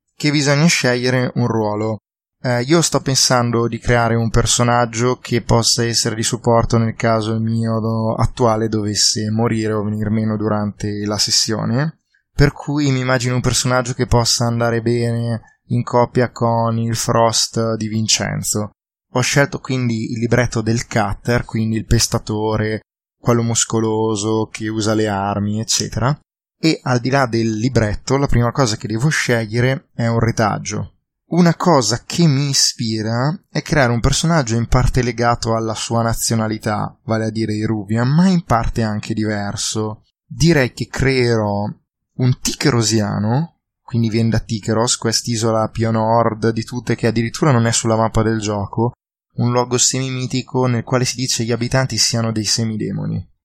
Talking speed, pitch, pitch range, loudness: 155 wpm, 115 Hz, 110-125 Hz, -17 LUFS